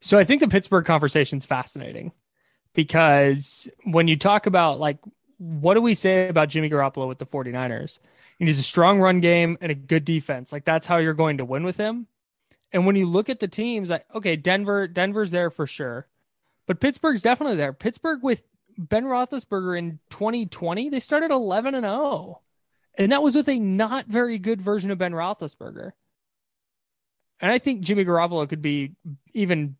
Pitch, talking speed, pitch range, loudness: 185 Hz, 185 wpm, 160-220 Hz, -22 LUFS